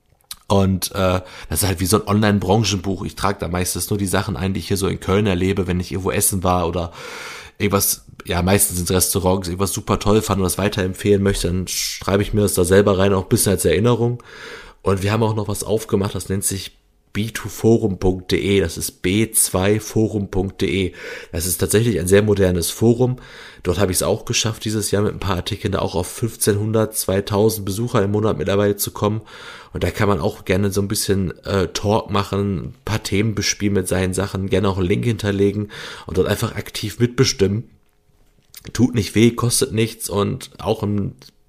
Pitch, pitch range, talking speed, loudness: 100 Hz, 95-110 Hz, 200 wpm, -19 LUFS